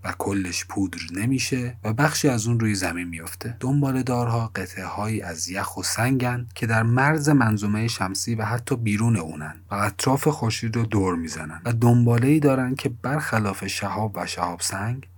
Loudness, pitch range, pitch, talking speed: -23 LUFS, 95-125 Hz, 110 Hz, 175 wpm